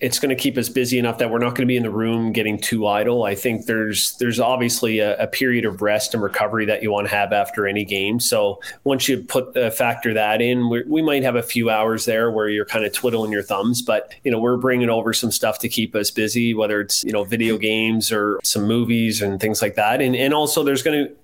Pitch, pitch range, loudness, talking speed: 115 Hz, 105-125 Hz, -19 LUFS, 265 wpm